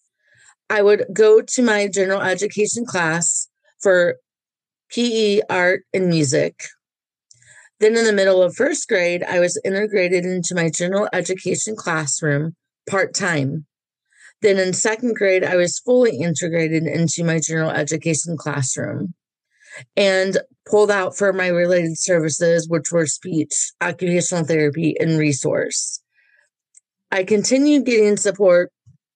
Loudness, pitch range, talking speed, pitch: -18 LUFS, 165-205 Hz, 125 wpm, 180 Hz